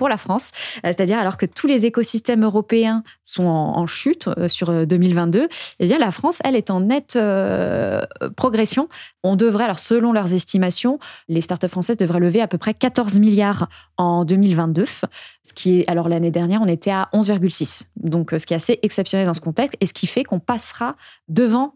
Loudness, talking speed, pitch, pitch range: -19 LUFS, 195 wpm, 200 Hz, 175-235 Hz